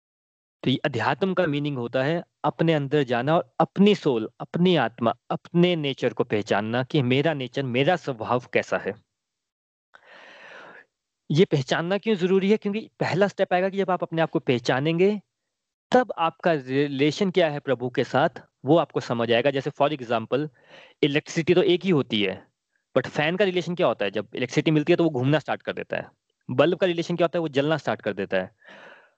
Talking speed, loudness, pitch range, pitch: 190 wpm, -24 LUFS, 135-175 Hz, 155 Hz